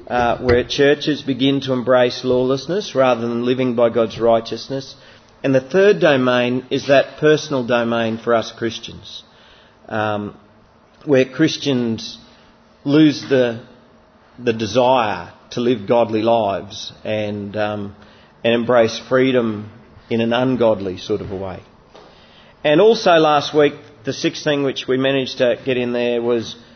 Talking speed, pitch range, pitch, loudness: 140 wpm, 115-135 Hz, 125 Hz, -17 LUFS